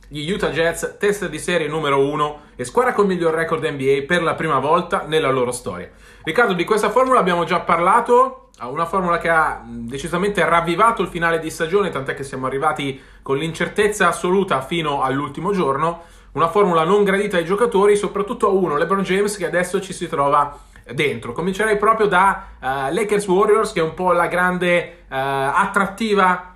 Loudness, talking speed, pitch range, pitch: -18 LUFS, 180 wpm, 155-200 Hz, 175 Hz